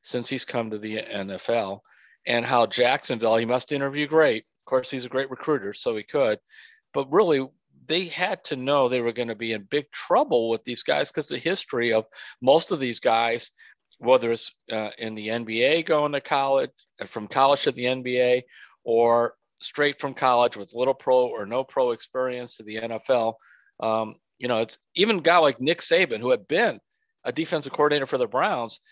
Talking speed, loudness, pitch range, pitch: 195 wpm, -24 LUFS, 115-145 Hz, 125 Hz